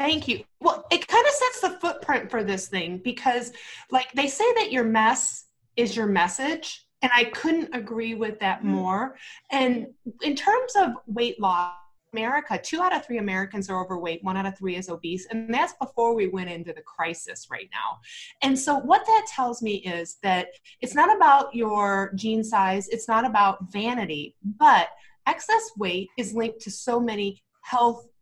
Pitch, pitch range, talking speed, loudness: 230 Hz, 195-280 Hz, 185 wpm, -24 LUFS